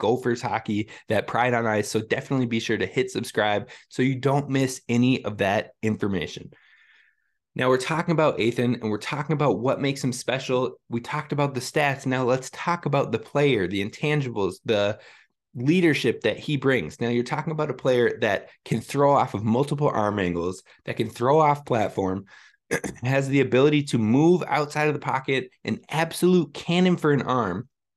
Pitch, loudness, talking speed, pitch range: 130 Hz, -24 LUFS, 185 wpm, 115-145 Hz